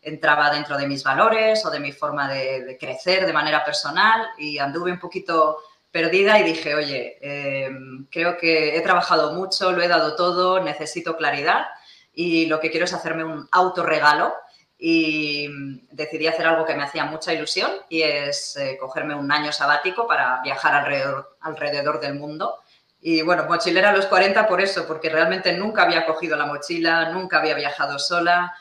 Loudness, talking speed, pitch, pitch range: -20 LUFS, 175 wpm, 160 Hz, 145-175 Hz